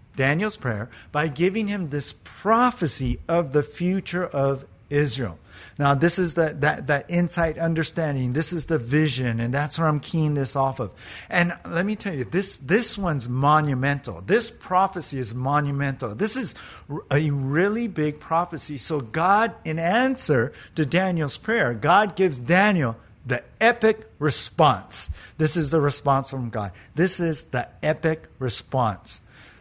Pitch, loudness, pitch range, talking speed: 150 Hz, -23 LUFS, 130-175 Hz, 150 wpm